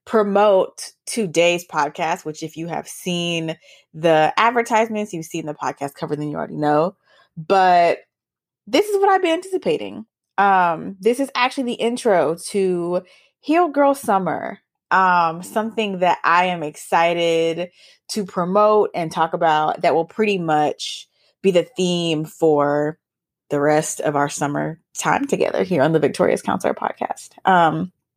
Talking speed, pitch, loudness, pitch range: 145 wpm, 175 Hz, -19 LUFS, 160-210 Hz